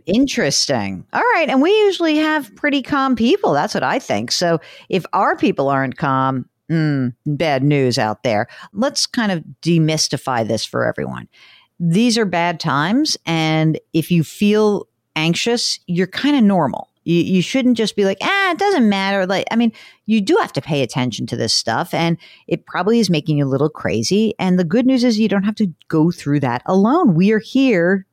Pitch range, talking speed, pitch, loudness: 150-230 Hz, 195 wpm, 180 Hz, -17 LUFS